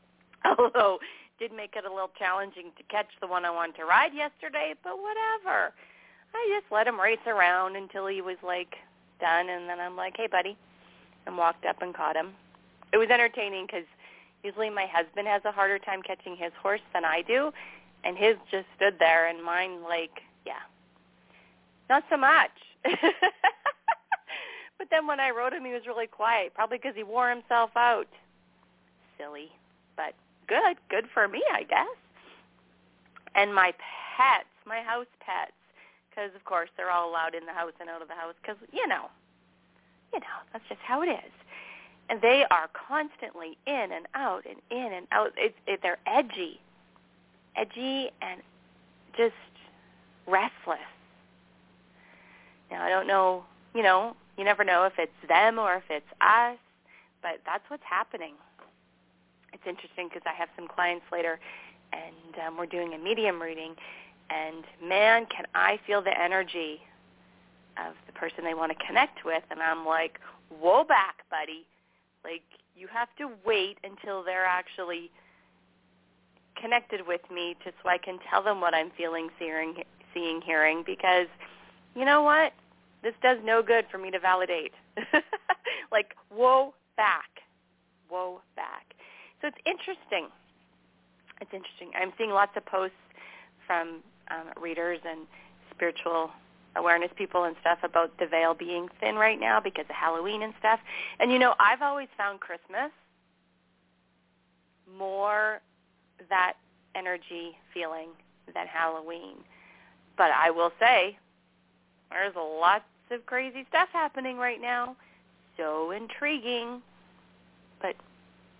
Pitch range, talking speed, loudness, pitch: 170-235 Hz, 150 wpm, -28 LUFS, 190 Hz